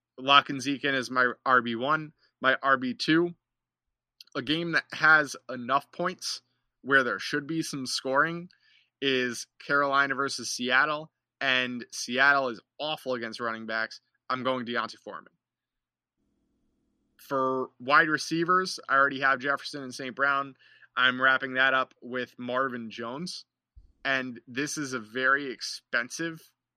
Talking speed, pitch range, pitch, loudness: 130 wpm, 125-145 Hz, 135 Hz, -27 LUFS